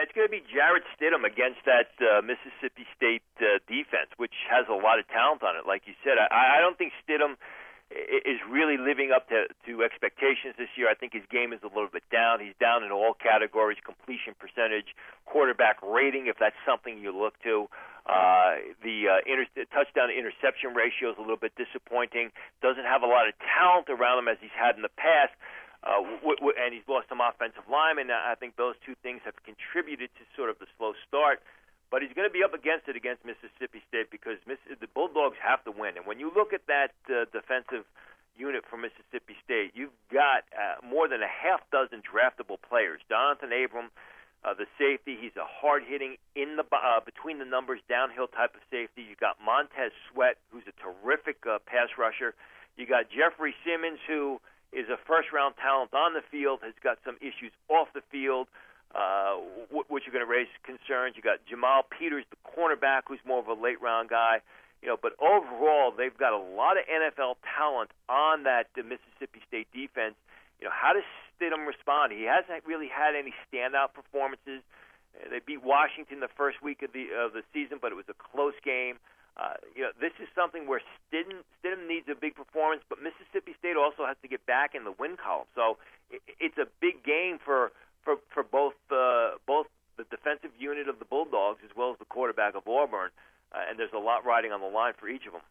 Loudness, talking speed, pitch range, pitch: -28 LUFS, 205 wpm, 120-155 Hz, 135 Hz